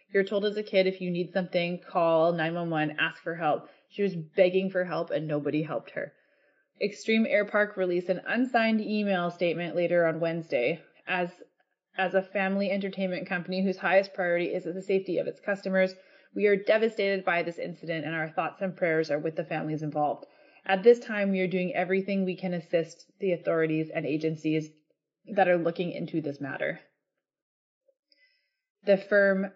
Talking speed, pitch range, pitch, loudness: 180 wpm, 165-195 Hz, 185 Hz, -28 LUFS